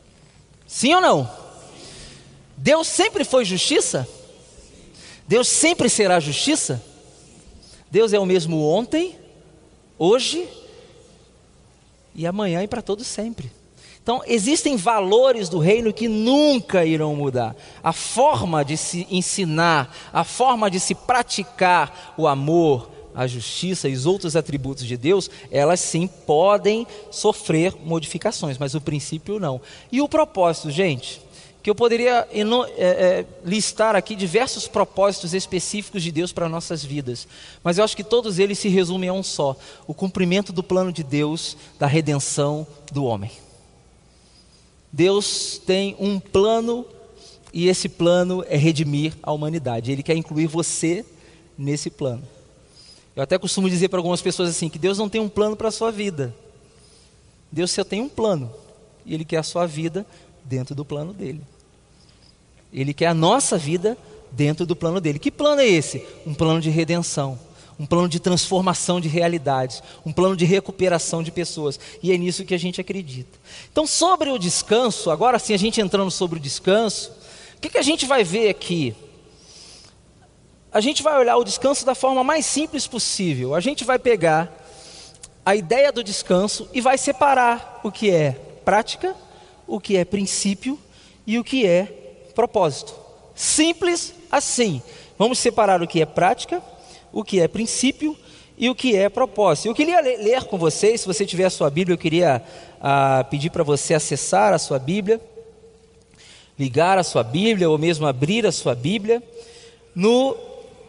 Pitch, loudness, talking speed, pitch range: 185 Hz, -20 LUFS, 160 wpm, 160-225 Hz